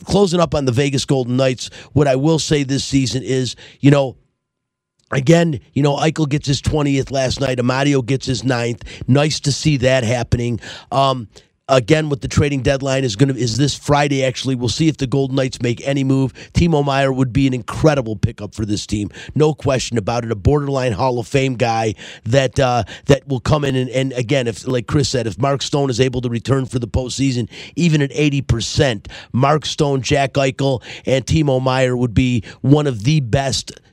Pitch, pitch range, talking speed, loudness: 130 Hz, 125-140 Hz, 205 wpm, -17 LUFS